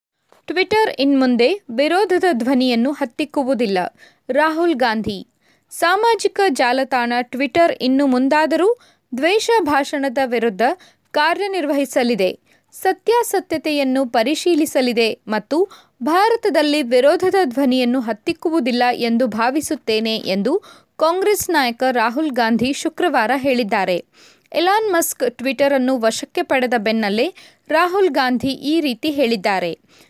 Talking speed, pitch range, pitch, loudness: 90 wpm, 245-340 Hz, 280 Hz, -18 LUFS